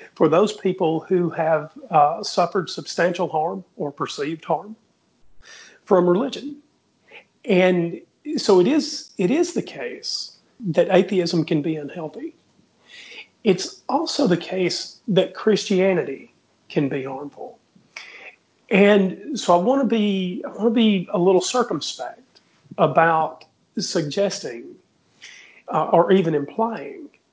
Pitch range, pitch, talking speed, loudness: 165-225 Hz, 185 Hz, 115 wpm, -21 LUFS